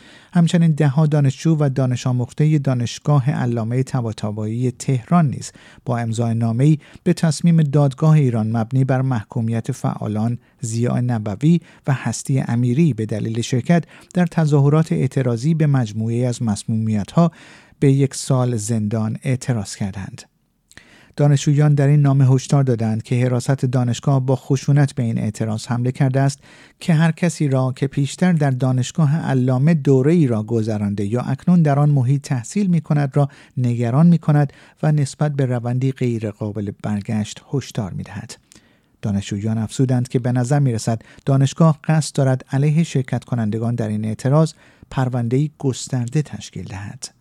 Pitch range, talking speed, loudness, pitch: 115-150 Hz, 145 wpm, -19 LUFS, 130 Hz